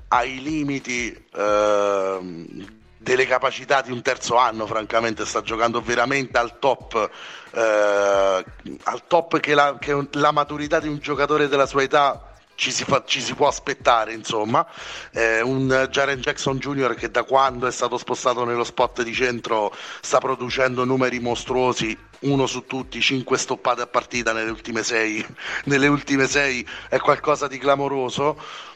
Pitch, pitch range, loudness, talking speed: 130 Hz, 115-140 Hz, -21 LUFS, 150 wpm